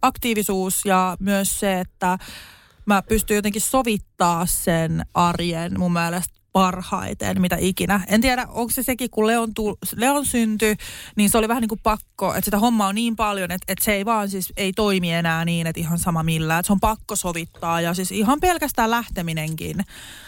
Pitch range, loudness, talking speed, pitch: 180-220 Hz, -21 LUFS, 185 wpm, 195 Hz